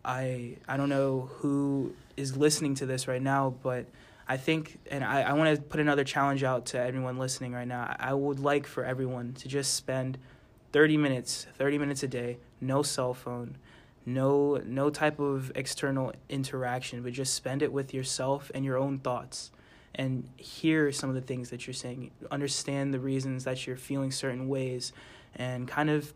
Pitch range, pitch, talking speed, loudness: 125-140 Hz, 135 Hz, 185 wpm, -31 LUFS